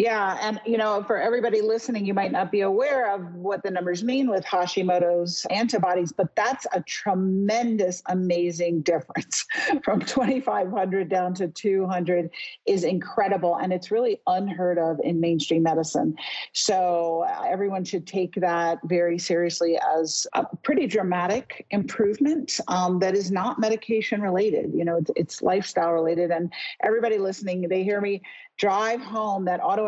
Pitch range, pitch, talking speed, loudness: 175-220 Hz, 190 Hz, 155 wpm, -24 LUFS